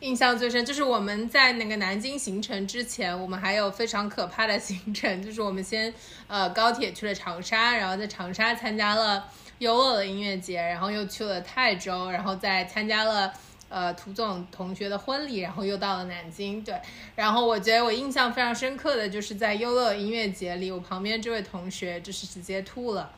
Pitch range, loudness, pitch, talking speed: 190-230 Hz, -27 LUFS, 210 Hz, 305 characters per minute